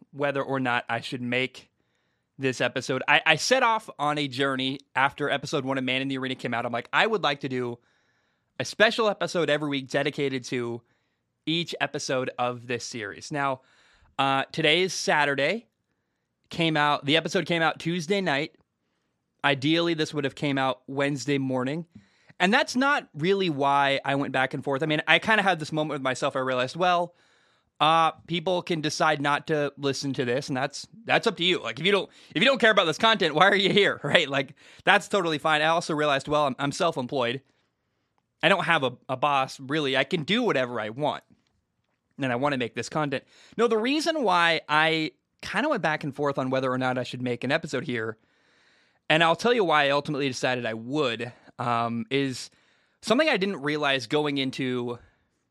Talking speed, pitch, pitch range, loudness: 205 wpm, 145 Hz, 130-165 Hz, -25 LUFS